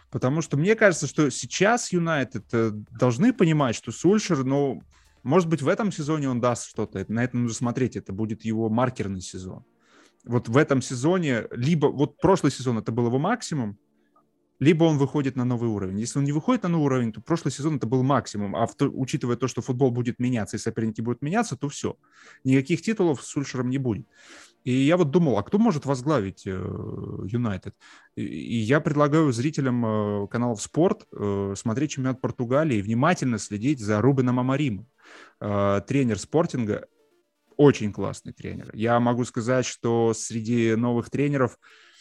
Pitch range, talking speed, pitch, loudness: 115-150 Hz, 165 wpm, 130 Hz, -24 LUFS